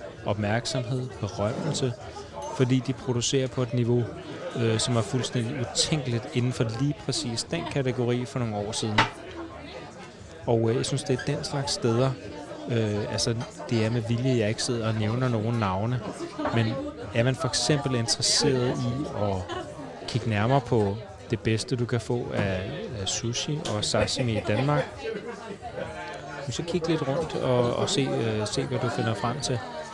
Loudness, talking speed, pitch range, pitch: -27 LUFS, 160 wpm, 110-130 Hz, 120 Hz